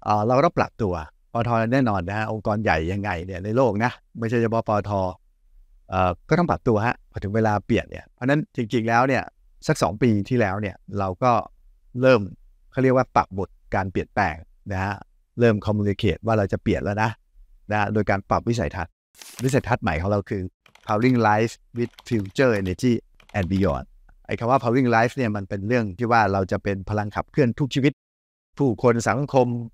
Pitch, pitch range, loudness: 105 Hz, 95-120 Hz, -23 LUFS